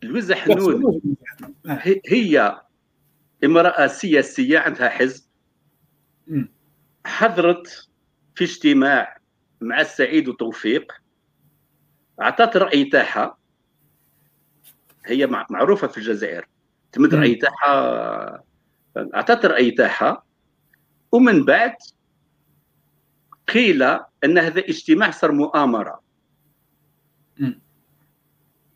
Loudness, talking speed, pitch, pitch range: -18 LUFS, 65 wpm, 175 Hz, 150-240 Hz